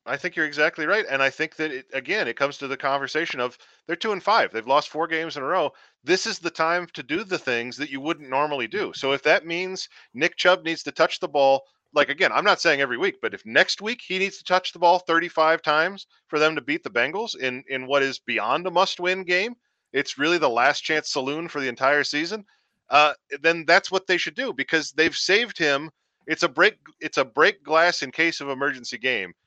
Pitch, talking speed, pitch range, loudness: 160 Hz, 245 wpm, 140-180 Hz, -23 LUFS